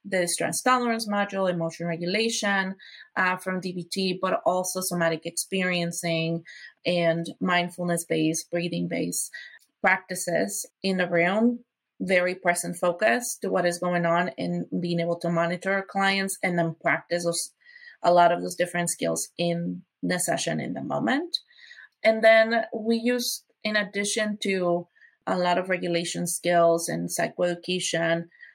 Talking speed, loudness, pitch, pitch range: 140 wpm, -25 LUFS, 180 Hz, 170-195 Hz